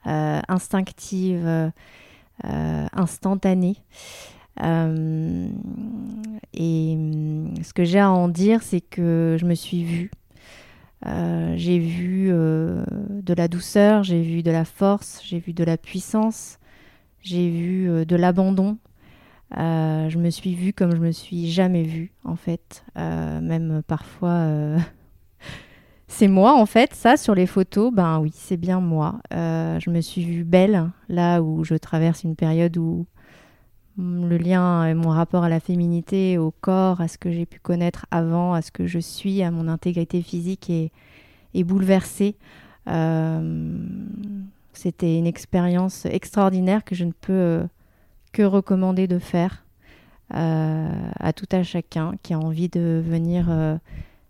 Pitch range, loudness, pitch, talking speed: 165-190 Hz, -22 LUFS, 175 Hz, 150 wpm